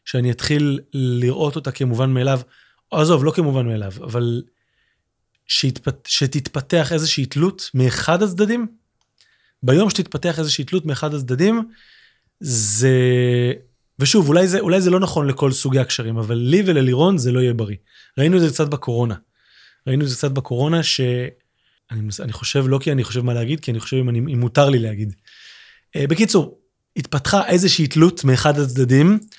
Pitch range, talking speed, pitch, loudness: 125-160 Hz, 150 wpm, 140 Hz, -18 LUFS